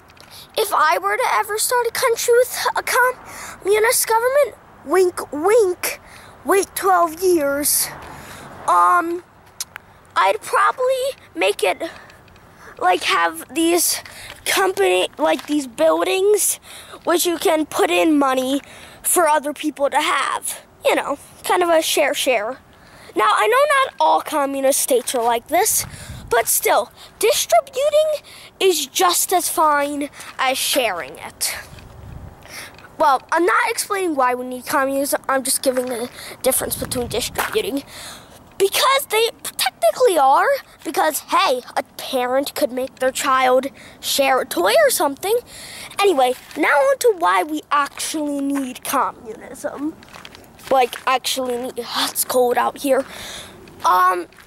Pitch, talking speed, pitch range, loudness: 300 Hz, 125 wpm, 265-380 Hz, -18 LUFS